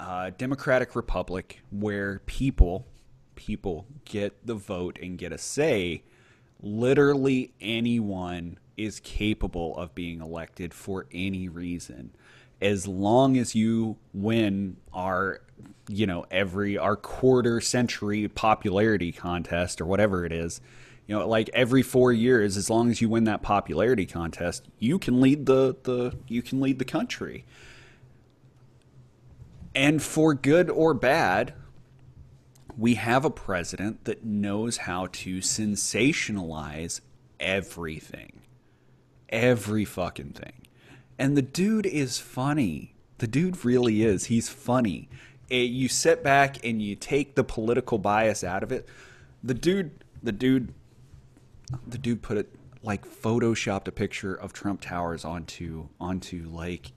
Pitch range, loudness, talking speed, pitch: 95-125 Hz, -26 LUFS, 130 wpm, 110 Hz